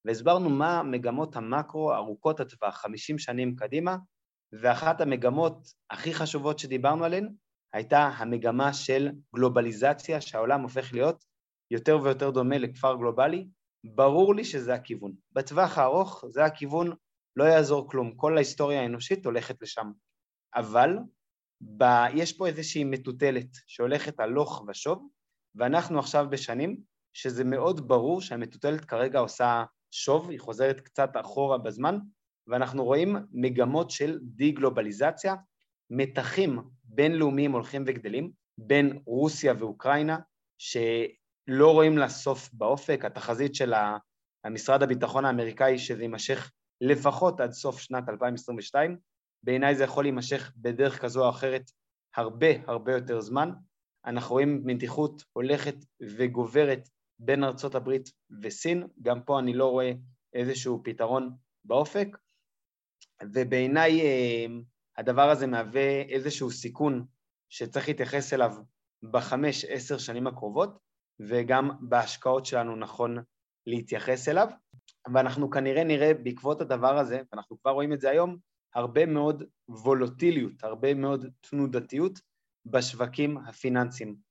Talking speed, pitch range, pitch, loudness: 115 wpm, 120-145 Hz, 135 Hz, -28 LUFS